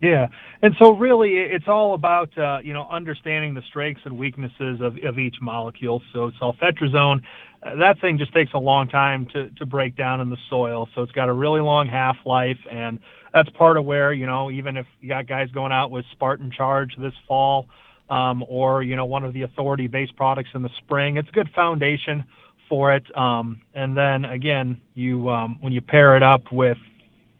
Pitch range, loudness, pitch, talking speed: 125-145 Hz, -20 LUFS, 135 Hz, 200 wpm